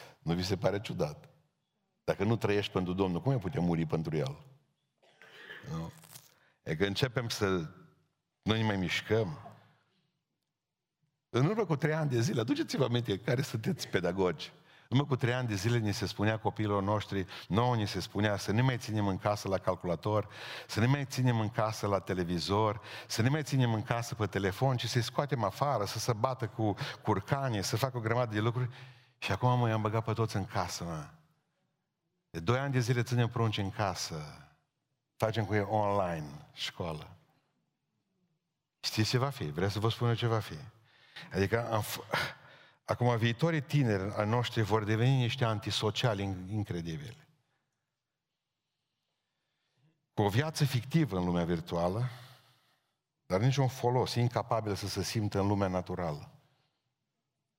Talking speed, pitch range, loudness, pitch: 165 wpm, 100-135 Hz, -32 LUFS, 115 Hz